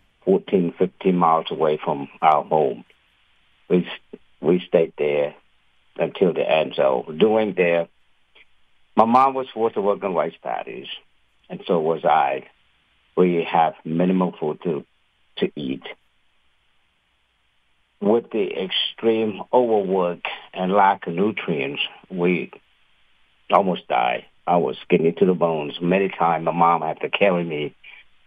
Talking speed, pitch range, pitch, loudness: 130 wpm, 75-95 Hz, 85 Hz, -21 LUFS